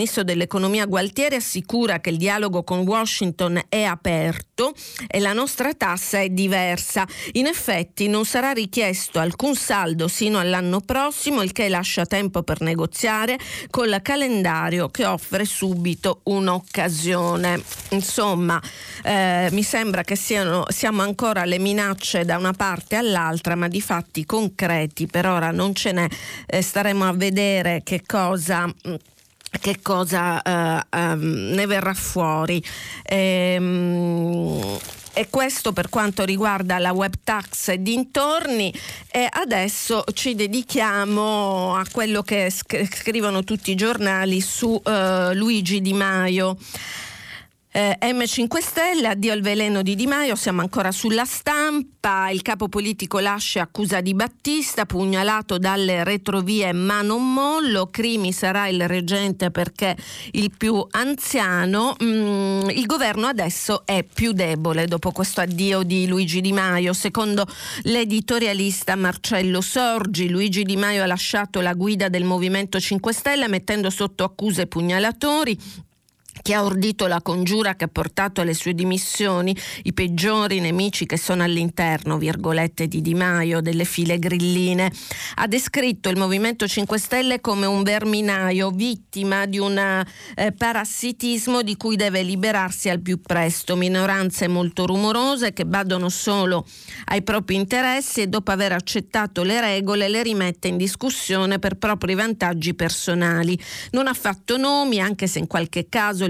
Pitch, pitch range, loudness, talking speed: 195 Hz, 180-215 Hz, -21 LUFS, 140 wpm